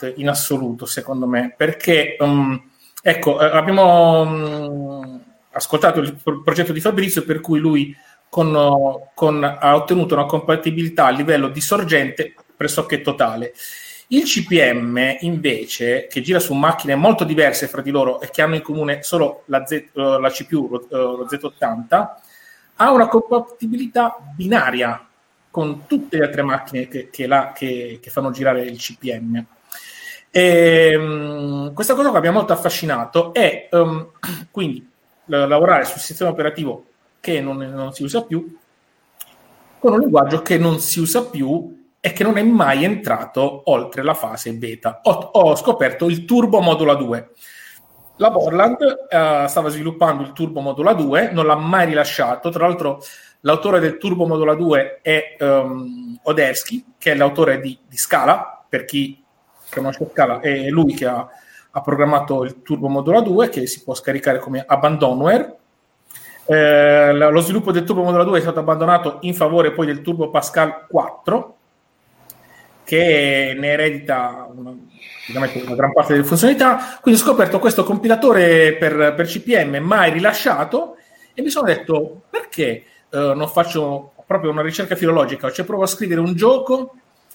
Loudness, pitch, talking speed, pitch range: -17 LUFS, 155 Hz, 150 wpm, 140-175 Hz